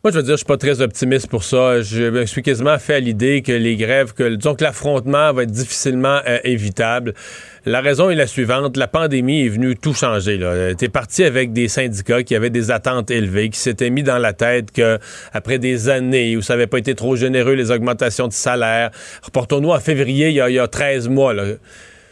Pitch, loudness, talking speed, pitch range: 125 Hz, -17 LUFS, 225 wpm, 120-140 Hz